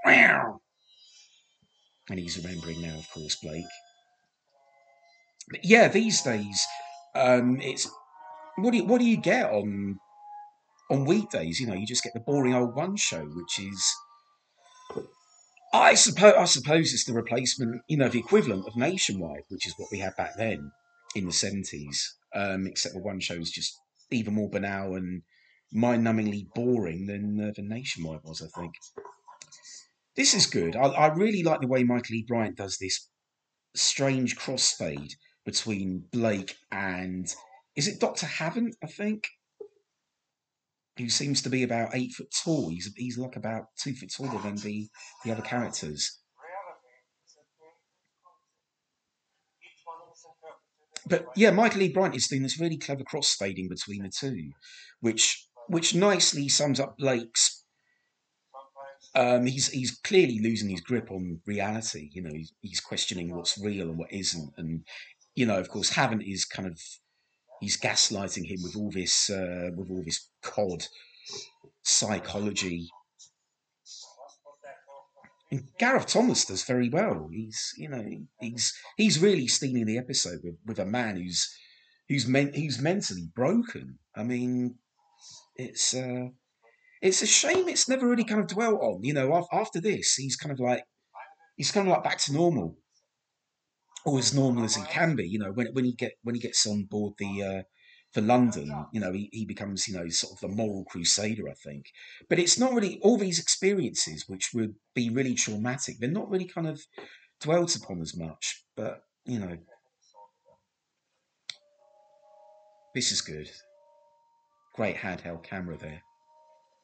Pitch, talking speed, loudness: 125 Hz, 155 wpm, -27 LUFS